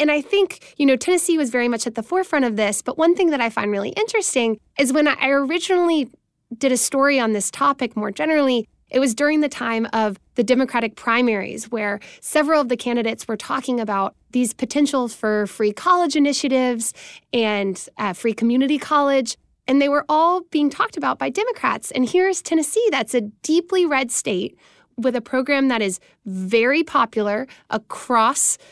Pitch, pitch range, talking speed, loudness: 260 Hz, 230-300 Hz, 185 wpm, -20 LUFS